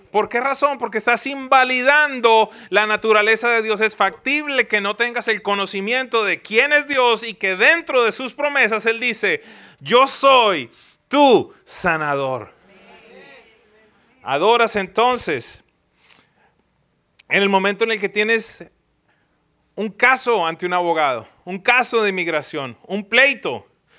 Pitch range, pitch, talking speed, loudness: 200-255 Hz, 225 Hz, 135 wpm, -17 LUFS